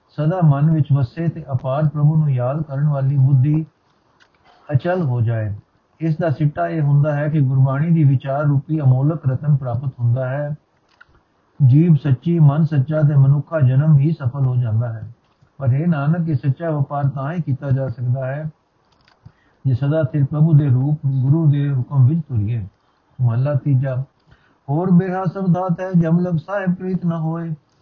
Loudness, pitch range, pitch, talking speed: -18 LUFS, 130-160 Hz, 145 Hz, 165 wpm